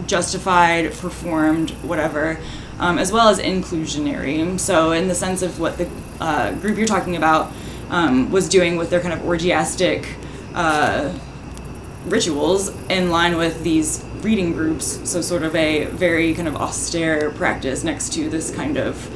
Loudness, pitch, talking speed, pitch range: -19 LUFS, 170 Hz, 155 wpm, 160-180 Hz